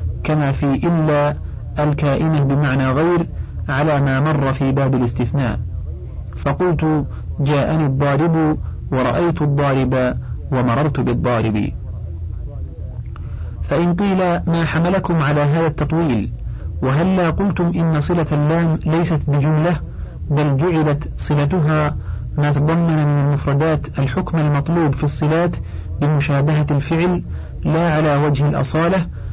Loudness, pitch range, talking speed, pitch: -18 LUFS, 130-160 Hz, 100 wpm, 145 Hz